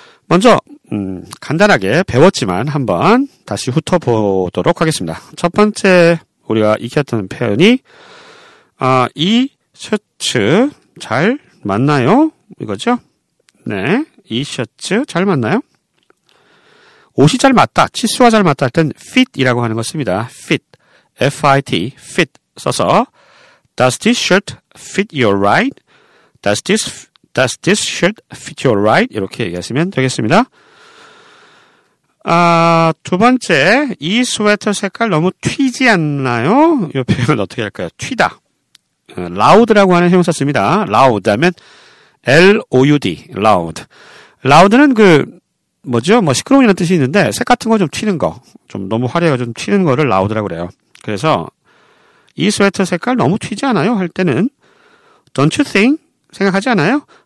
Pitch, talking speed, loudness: 180 Hz, 320 characters per minute, -13 LUFS